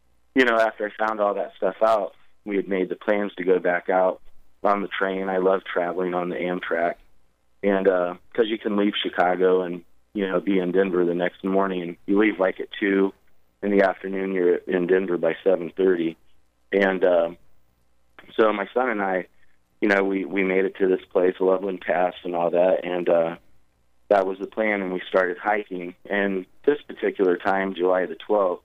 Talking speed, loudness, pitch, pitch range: 200 wpm, -23 LUFS, 95 Hz, 85-95 Hz